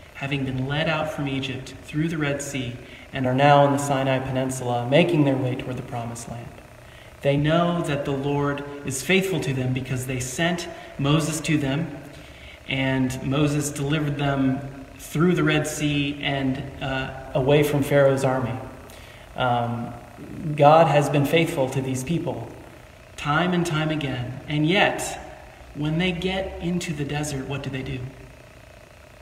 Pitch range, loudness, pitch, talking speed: 130-150 Hz, -23 LUFS, 140 Hz, 160 wpm